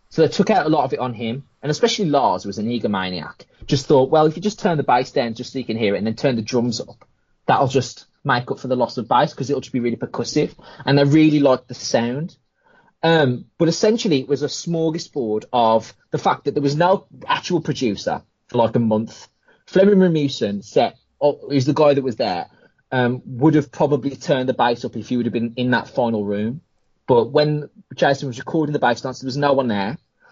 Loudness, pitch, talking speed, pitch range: -20 LUFS, 140 Hz, 235 wpm, 120-150 Hz